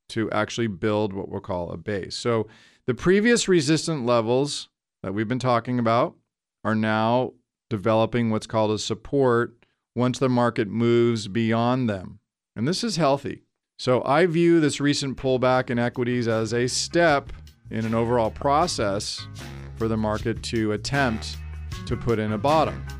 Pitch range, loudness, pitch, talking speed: 110-130 Hz, -23 LUFS, 120 Hz, 155 wpm